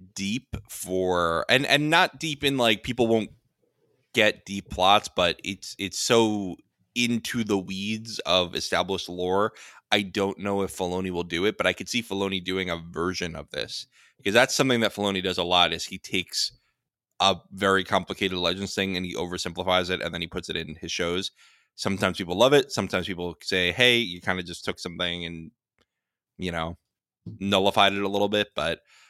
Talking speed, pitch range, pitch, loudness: 190 wpm, 90-105 Hz, 95 Hz, -25 LUFS